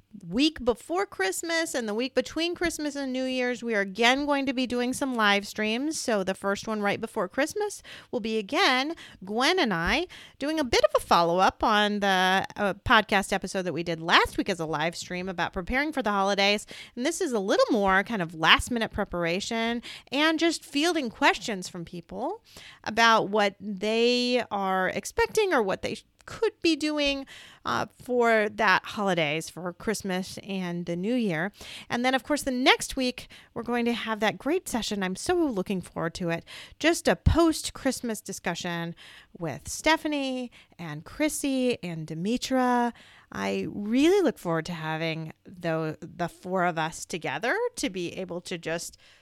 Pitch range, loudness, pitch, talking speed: 185-275 Hz, -26 LUFS, 225 Hz, 180 wpm